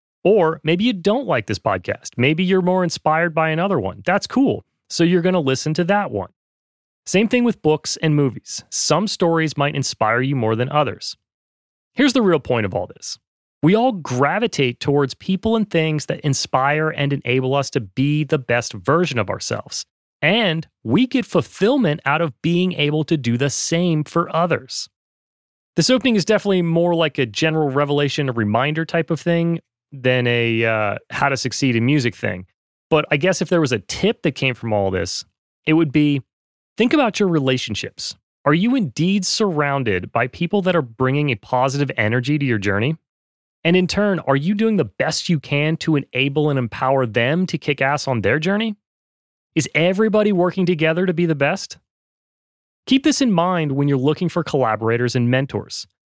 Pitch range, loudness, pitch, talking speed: 130-180 Hz, -19 LUFS, 155 Hz, 190 wpm